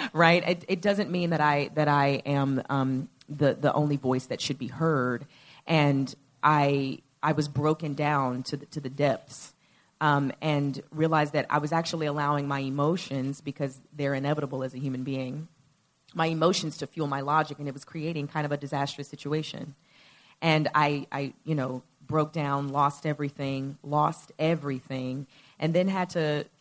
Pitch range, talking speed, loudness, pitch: 140-155 Hz, 180 wpm, -28 LUFS, 145 Hz